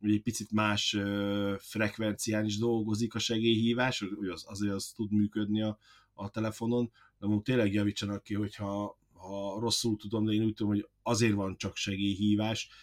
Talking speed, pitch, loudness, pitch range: 170 wpm, 105 Hz, -32 LUFS, 100-110 Hz